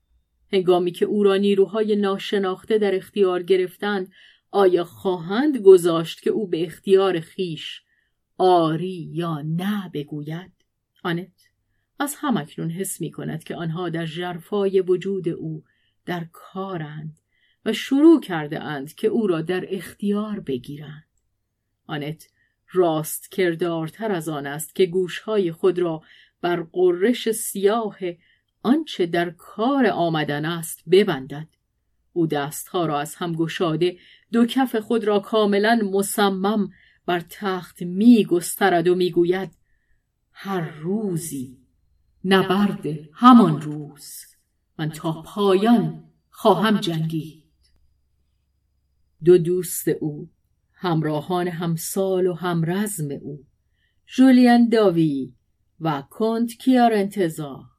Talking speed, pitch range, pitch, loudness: 110 wpm, 155-200 Hz, 180 Hz, -21 LUFS